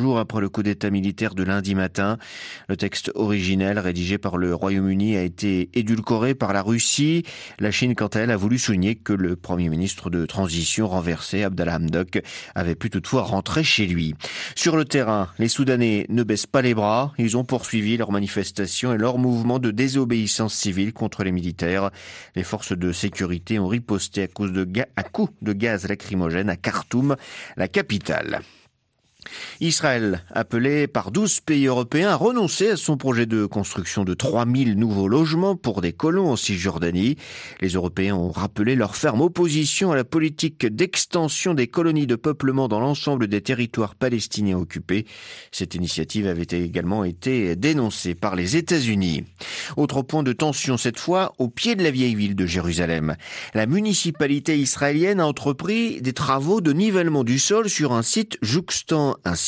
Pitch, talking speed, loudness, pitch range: 110 Hz, 170 wpm, -22 LUFS, 95-140 Hz